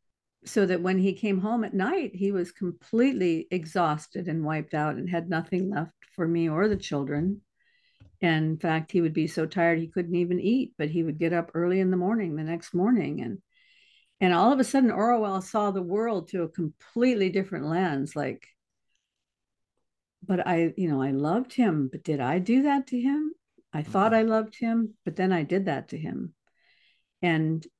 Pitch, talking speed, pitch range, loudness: 180 Hz, 195 wpm, 165-220 Hz, -27 LUFS